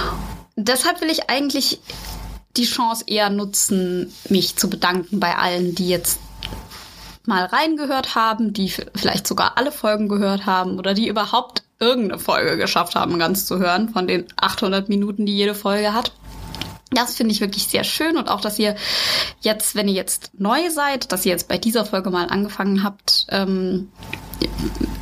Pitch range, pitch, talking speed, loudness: 185-230 Hz, 205 Hz, 165 wpm, -20 LUFS